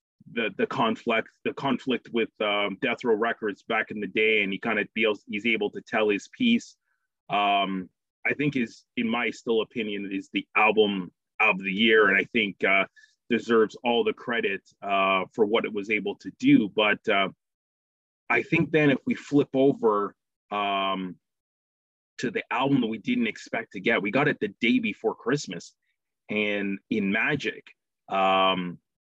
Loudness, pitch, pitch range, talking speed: -25 LUFS, 105 Hz, 95-140 Hz, 175 wpm